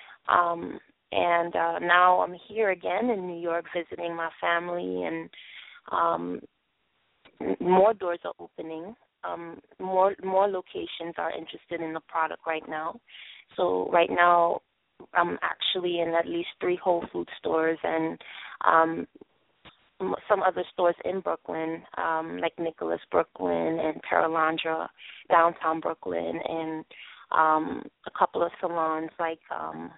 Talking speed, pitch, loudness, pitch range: 135 wpm, 165 Hz, -27 LUFS, 160-175 Hz